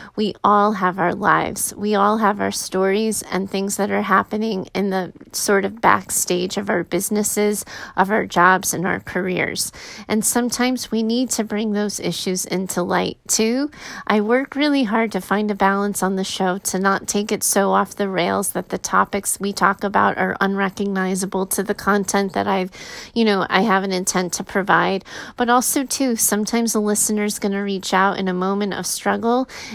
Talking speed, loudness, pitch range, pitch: 190 wpm, -19 LUFS, 190-215 Hz, 200 Hz